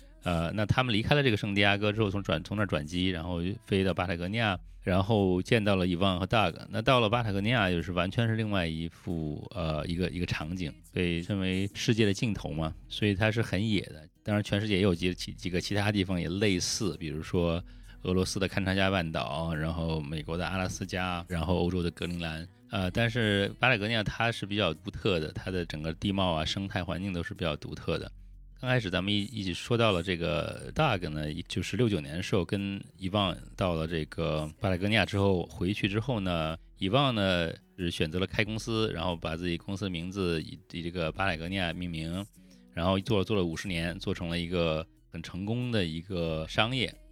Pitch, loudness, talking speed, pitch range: 95 Hz, -30 LUFS, 335 characters per minute, 85-105 Hz